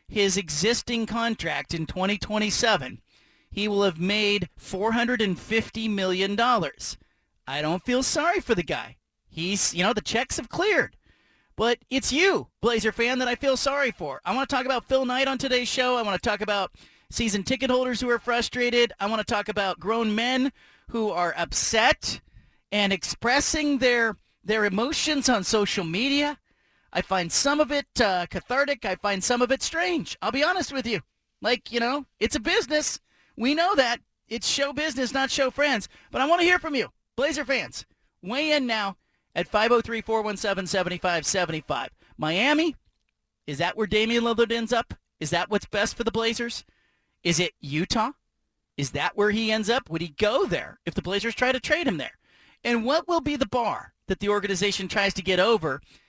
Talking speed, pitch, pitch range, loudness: 180 wpm, 225 Hz, 195-255 Hz, -25 LUFS